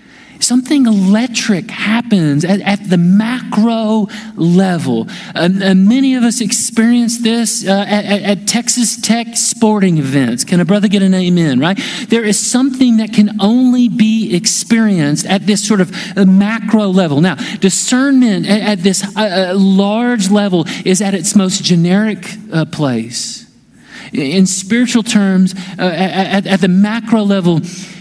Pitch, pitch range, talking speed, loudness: 205 Hz, 190-225 Hz, 150 wpm, -12 LUFS